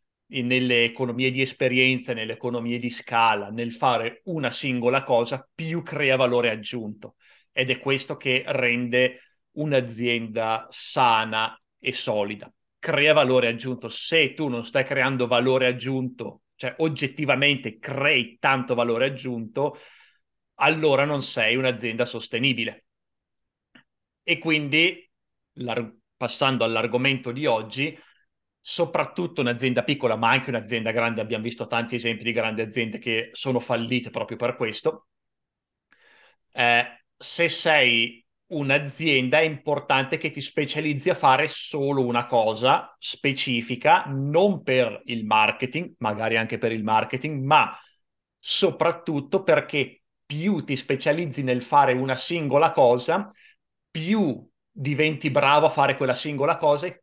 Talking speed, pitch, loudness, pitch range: 125 wpm, 130 Hz, -23 LUFS, 120-150 Hz